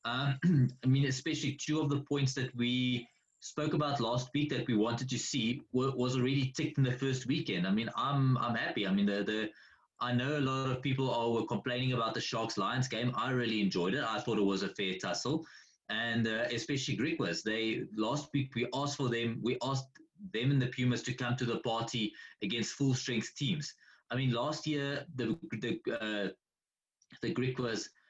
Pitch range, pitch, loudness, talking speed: 115-140 Hz, 125 Hz, -34 LUFS, 205 wpm